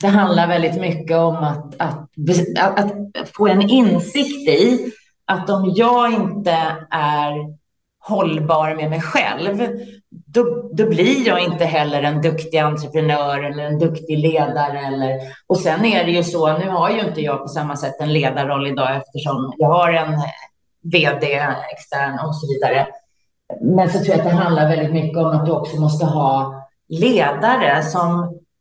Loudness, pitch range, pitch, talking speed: -17 LUFS, 150-190 Hz, 160 Hz, 165 wpm